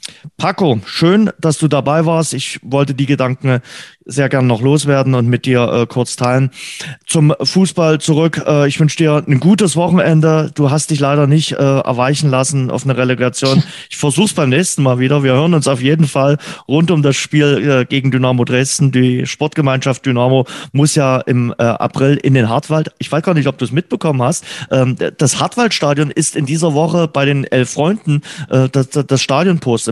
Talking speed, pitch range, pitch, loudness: 195 wpm, 130-155 Hz, 145 Hz, -13 LUFS